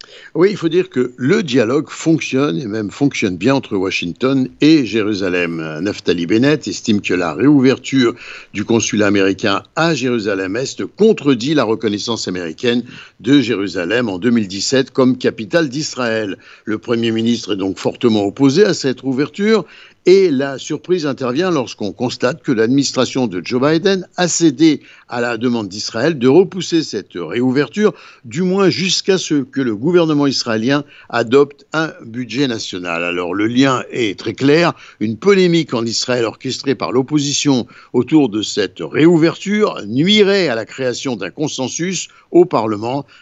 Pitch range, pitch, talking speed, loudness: 115-160 Hz, 130 Hz, 150 wpm, -16 LUFS